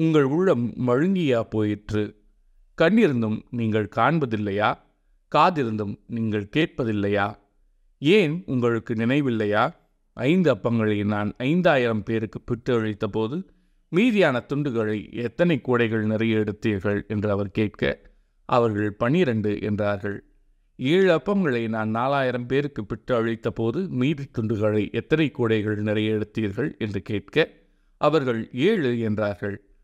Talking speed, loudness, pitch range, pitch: 100 wpm, -23 LUFS, 105-130 Hz, 115 Hz